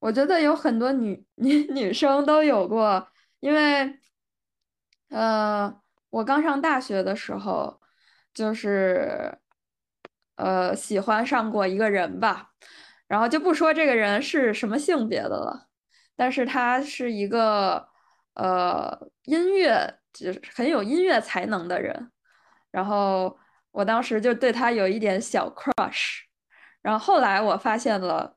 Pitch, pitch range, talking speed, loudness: 240 Hz, 205-290 Hz, 200 characters per minute, -24 LUFS